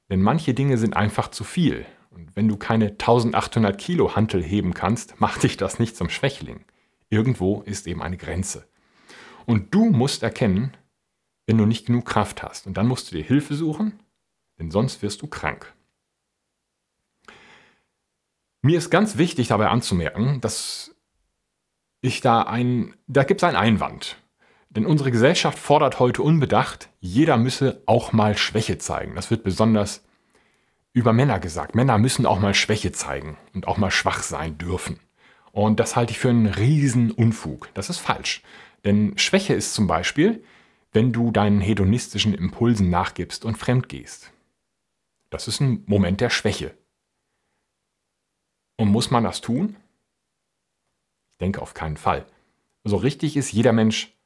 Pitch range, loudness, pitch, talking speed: 100-130 Hz, -22 LUFS, 115 Hz, 155 wpm